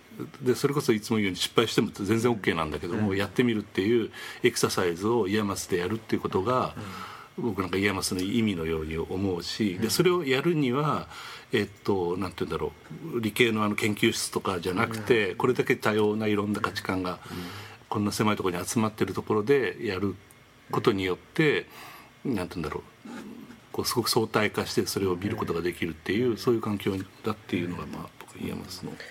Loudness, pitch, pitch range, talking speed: -27 LUFS, 105 Hz, 95-115 Hz, 425 characters per minute